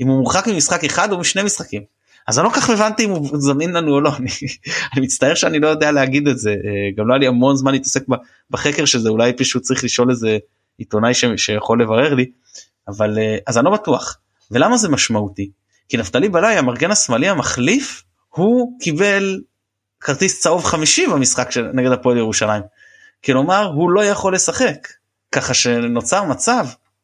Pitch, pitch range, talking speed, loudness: 130 Hz, 110-155 Hz, 175 wpm, -16 LUFS